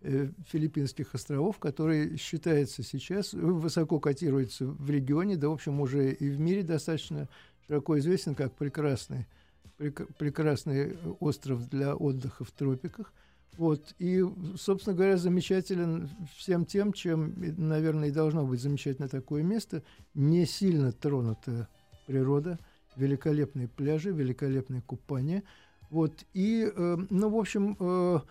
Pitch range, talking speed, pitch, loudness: 140-175 Hz, 125 wpm, 150 Hz, -31 LUFS